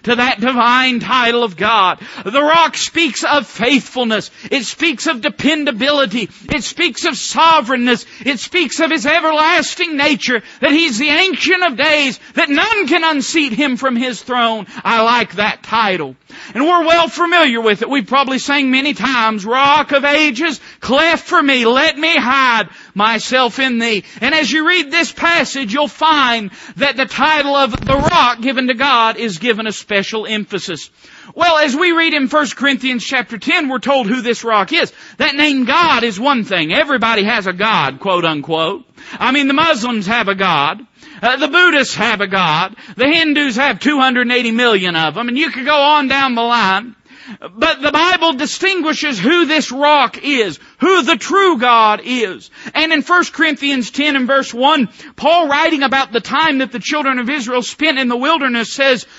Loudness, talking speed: -13 LUFS, 180 wpm